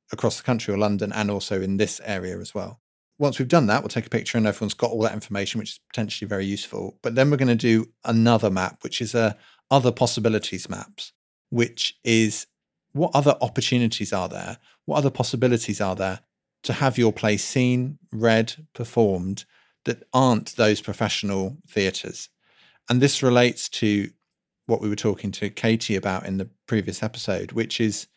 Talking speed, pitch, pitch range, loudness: 185 wpm, 110 Hz, 105-125 Hz, -23 LUFS